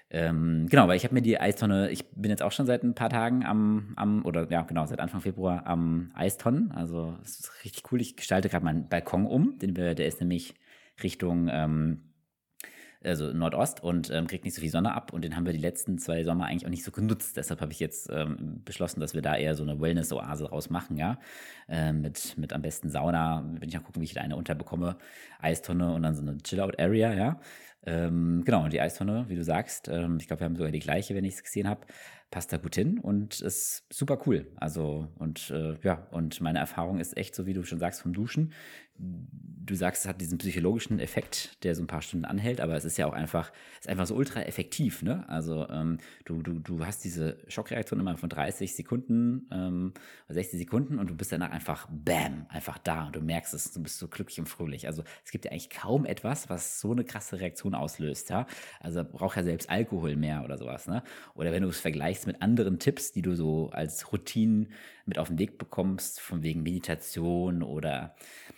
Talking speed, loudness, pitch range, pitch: 220 wpm, -31 LUFS, 80-95 Hz, 85 Hz